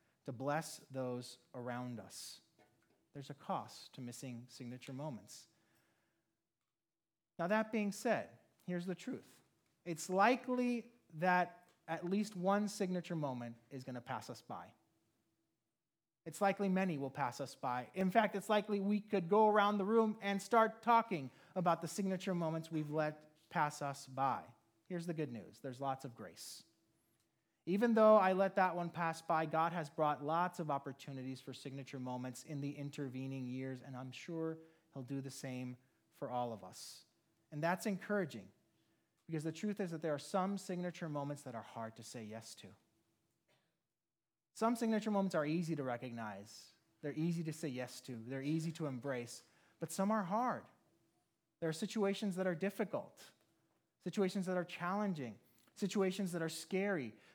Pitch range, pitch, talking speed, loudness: 130-190 Hz, 160 Hz, 165 wpm, -39 LUFS